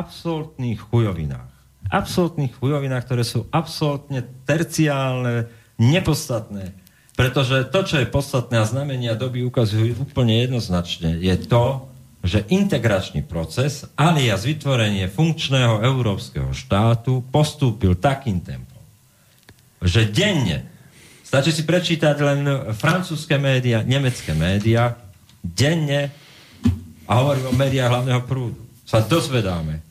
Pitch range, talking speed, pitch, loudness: 110-140 Hz, 105 wpm, 125 Hz, -20 LUFS